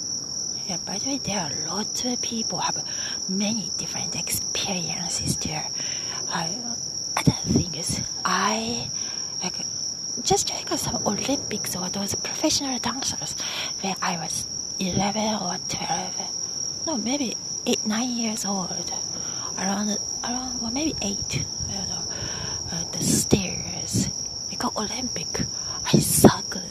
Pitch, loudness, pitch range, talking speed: 215 Hz, -25 LUFS, 190-245 Hz, 125 wpm